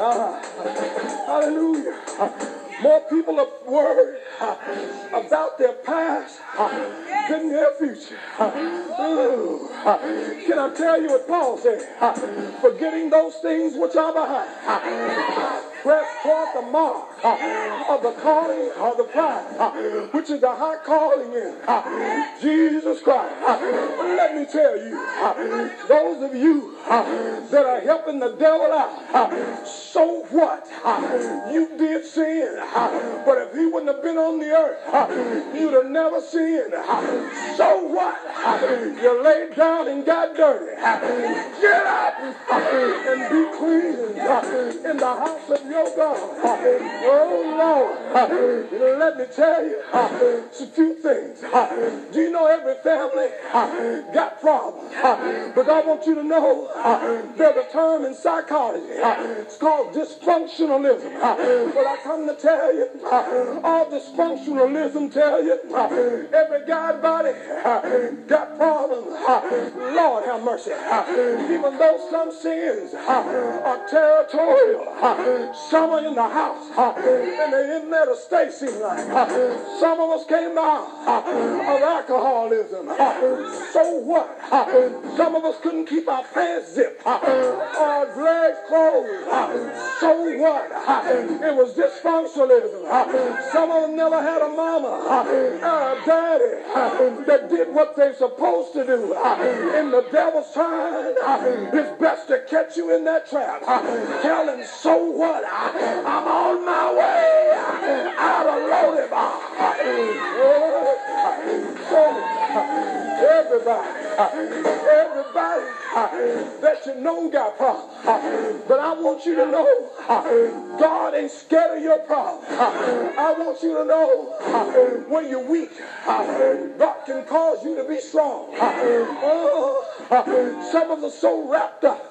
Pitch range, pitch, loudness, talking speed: 285-330 Hz, 315 Hz, -20 LUFS, 140 wpm